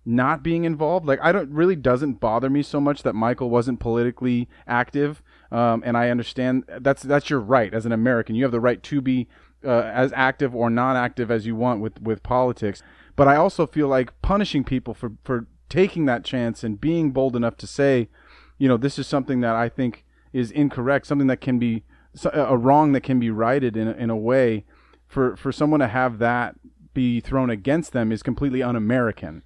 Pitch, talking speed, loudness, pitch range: 125 Hz, 205 wpm, -22 LUFS, 120-140 Hz